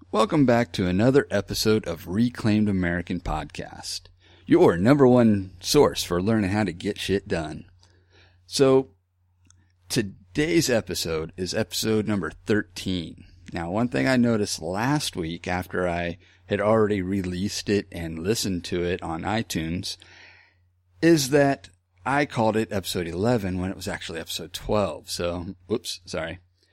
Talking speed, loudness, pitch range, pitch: 140 wpm, -24 LUFS, 90-110 Hz, 95 Hz